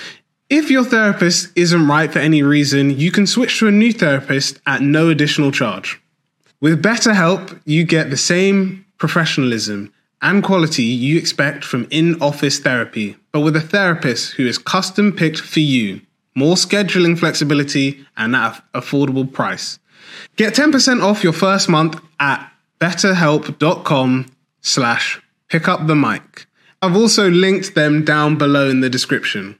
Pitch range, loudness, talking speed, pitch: 140-190 Hz, -15 LUFS, 150 wpm, 160 Hz